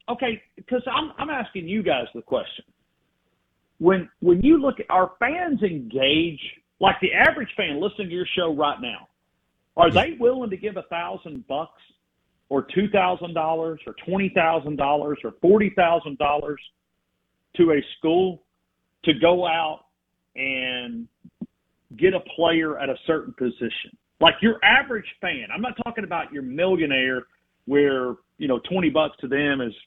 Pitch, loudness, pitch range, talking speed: 175 Hz, -22 LUFS, 145-205 Hz, 160 wpm